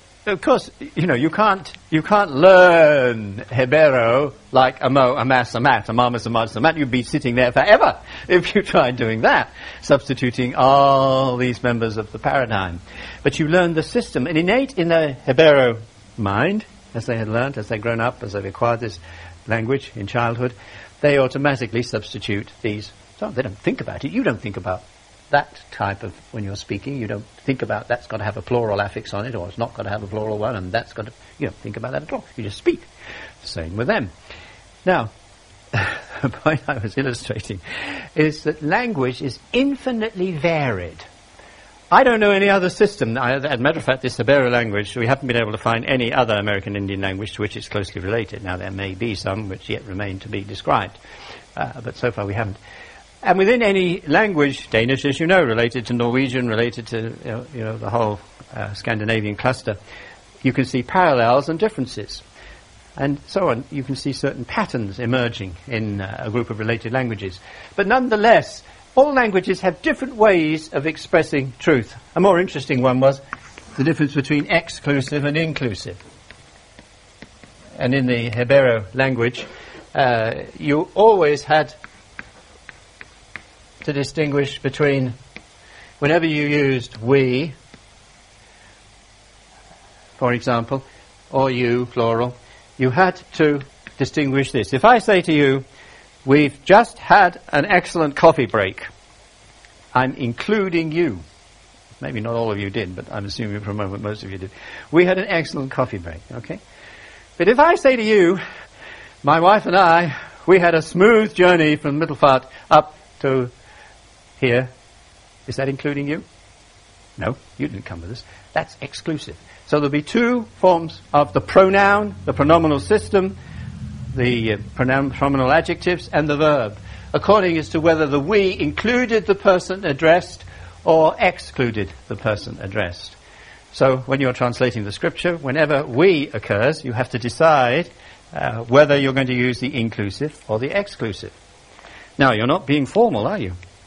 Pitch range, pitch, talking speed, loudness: 110-155 Hz, 125 Hz, 170 wpm, -19 LUFS